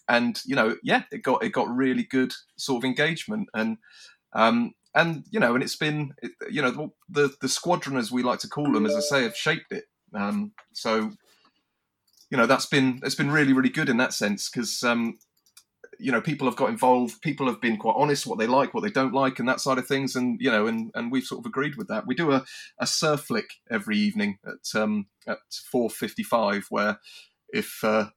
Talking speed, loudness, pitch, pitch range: 220 wpm, -25 LUFS, 130 Hz, 120-155 Hz